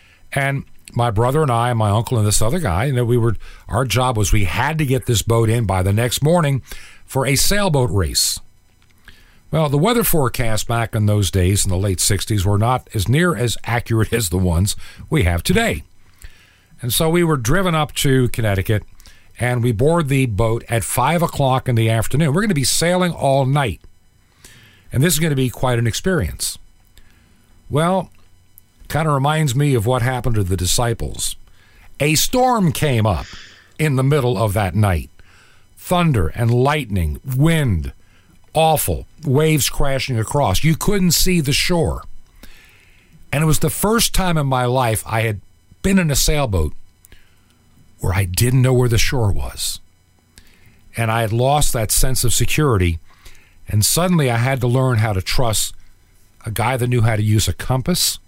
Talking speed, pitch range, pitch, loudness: 180 wpm, 95-140 Hz, 115 Hz, -18 LUFS